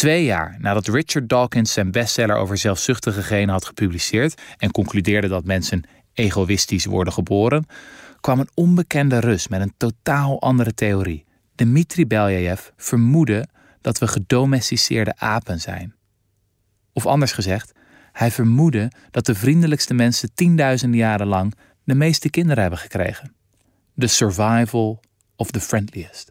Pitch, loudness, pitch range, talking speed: 110 Hz, -19 LUFS, 100-130 Hz, 130 wpm